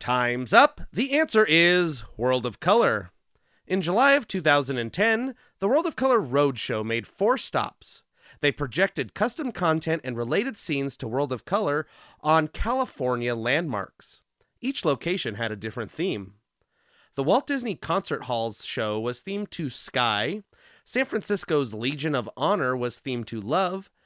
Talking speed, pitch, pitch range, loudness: 145 wpm, 150 Hz, 125-205 Hz, -25 LUFS